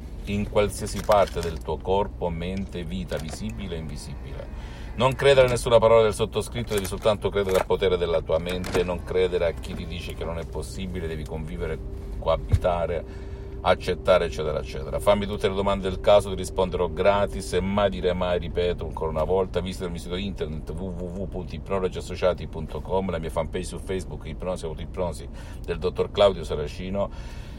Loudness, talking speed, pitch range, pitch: -25 LUFS, 165 wpm, 80-100 Hz, 90 Hz